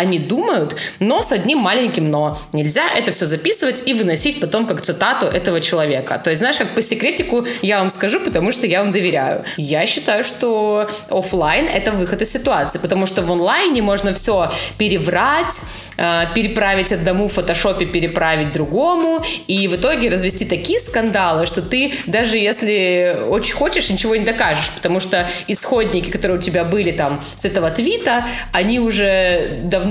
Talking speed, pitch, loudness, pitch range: 165 wpm, 195 Hz, -13 LUFS, 175-225 Hz